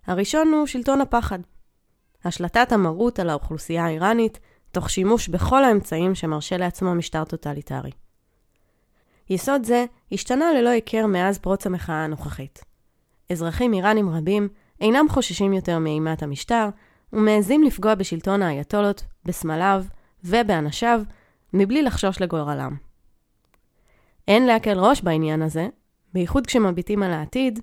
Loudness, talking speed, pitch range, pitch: -22 LUFS, 115 wpm, 170-230 Hz, 195 Hz